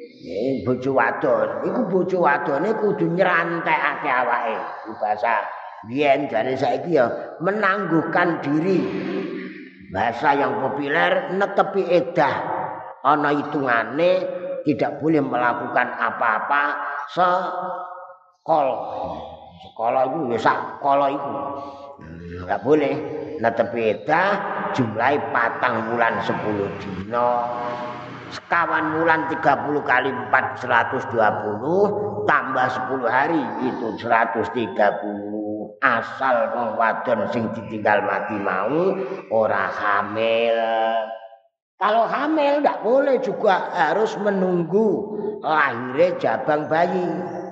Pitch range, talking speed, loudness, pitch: 115-180 Hz, 90 wpm, -21 LUFS, 145 Hz